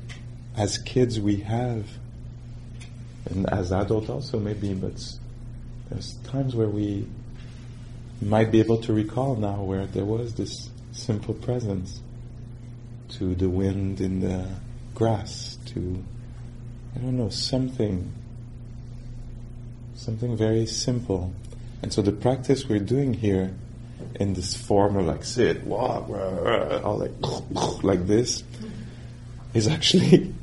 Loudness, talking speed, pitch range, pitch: -26 LUFS, 120 wpm, 105-120 Hz, 120 Hz